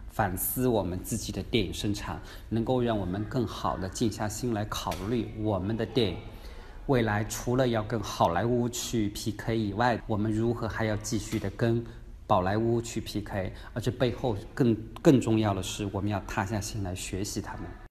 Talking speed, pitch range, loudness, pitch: 270 characters per minute, 100-115 Hz, -29 LUFS, 110 Hz